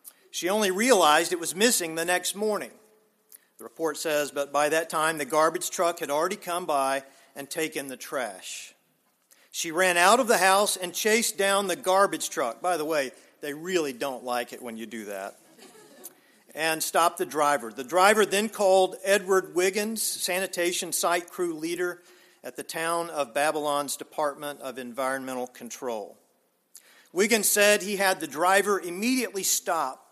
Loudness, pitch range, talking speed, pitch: -25 LUFS, 150-195 Hz, 165 wpm, 175 Hz